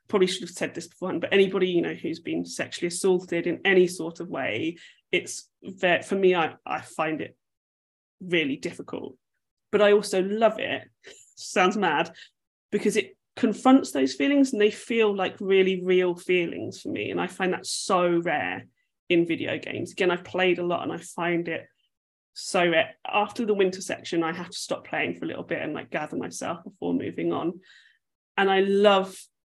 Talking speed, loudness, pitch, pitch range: 190 wpm, -25 LUFS, 190 Hz, 175-210 Hz